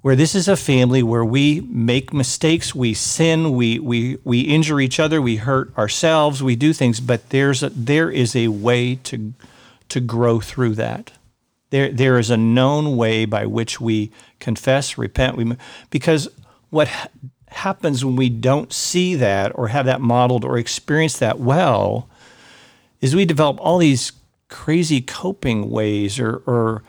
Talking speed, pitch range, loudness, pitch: 165 wpm, 120-145 Hz, -18 LUFS, 130 Hz